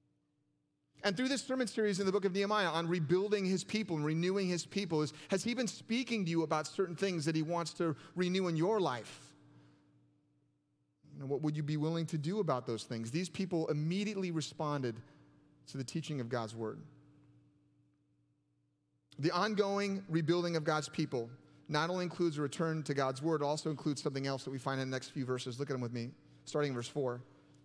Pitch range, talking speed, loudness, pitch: 130-180 Hz, 200 wpm, -36 LUFS, 155 Hz